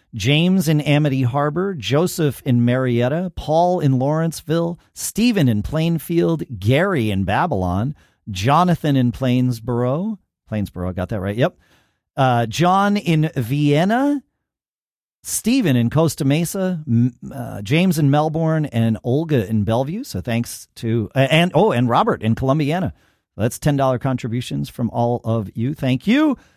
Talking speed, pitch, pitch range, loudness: 140 wpm, 135 Hz, 120-165 Hz, -19 LUFS